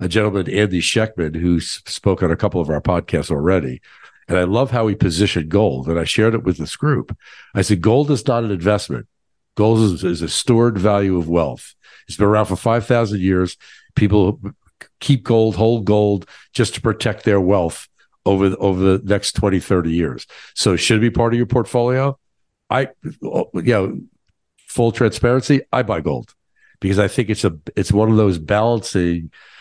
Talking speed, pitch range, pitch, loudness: 185 wpm, 90-115 Hz, 105 Hz, -18 LUFS